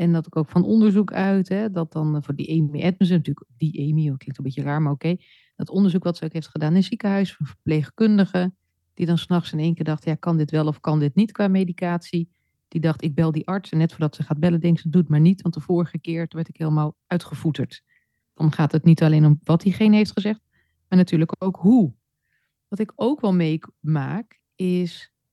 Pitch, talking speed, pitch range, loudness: 165 Hz, 230 wpm, 155-185 Hz, -22 LUFS